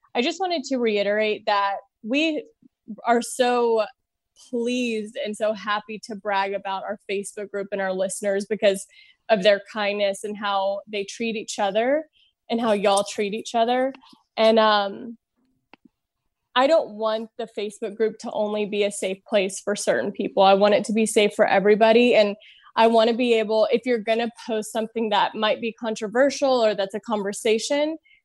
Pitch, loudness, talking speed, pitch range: 220 Hz, -22 LUFS, 175 wpm, 205-235 Hz